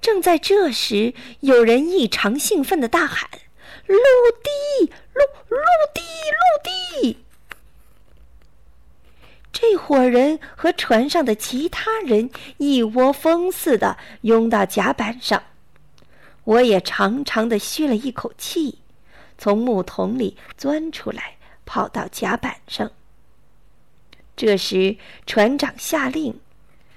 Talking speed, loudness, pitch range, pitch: 150 characters per minute, -19 LUFS, 225-335 Hz, 275 Hz